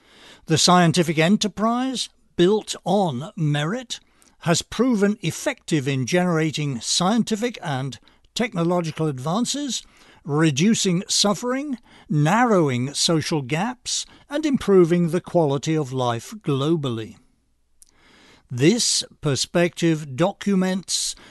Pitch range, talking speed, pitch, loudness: 155-210 Hz, 85 wpm, 175 Hz, -21 LUFS